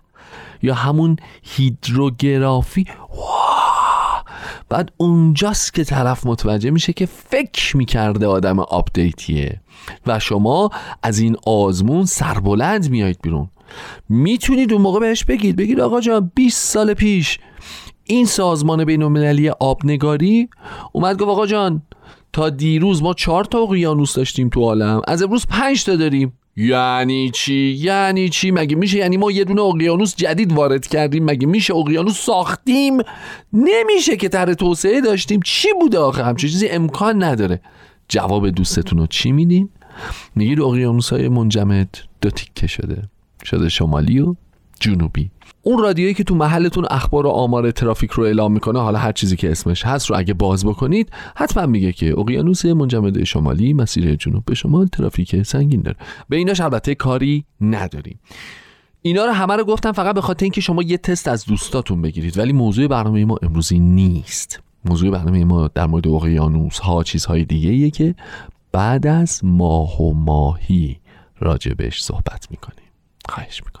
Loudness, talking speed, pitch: -17 LUFS, 150 wpm, 135 Hz